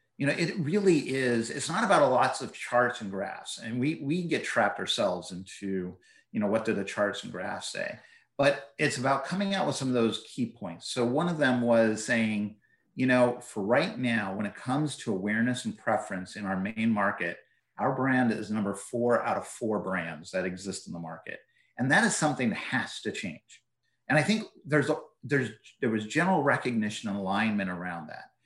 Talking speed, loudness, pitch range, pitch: 210 wpm, -29 LUFS, 105-145 Hz, 120 Hz